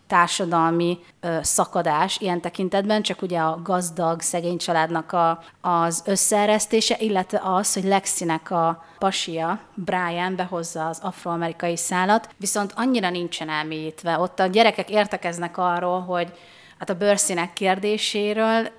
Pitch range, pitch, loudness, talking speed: 170-200 Hz, 180 Hz, -22 LUFS, 125 wpm